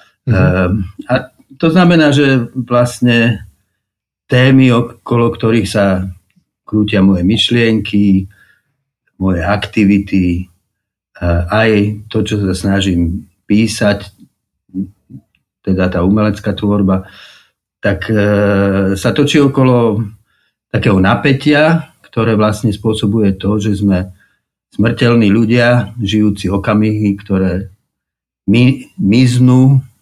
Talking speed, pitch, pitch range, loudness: 90 wpm, 105 Hz, 100-120 Hz, -12 LUFS